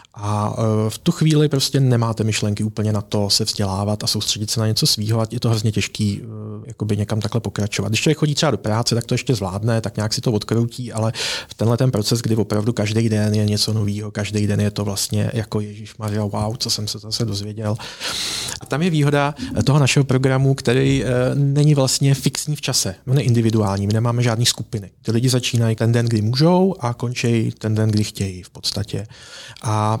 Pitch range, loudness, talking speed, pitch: 105-125 Hz, -19 LUFS, 205 wpm, 110 Hz